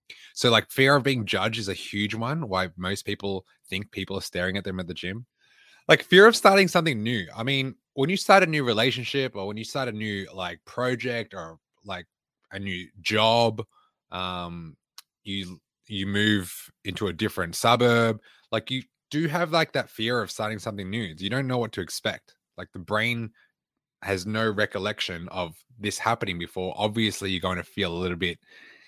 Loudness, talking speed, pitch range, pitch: -25 LUFS, 190 wpm, 95-120 Hz, 105 Hz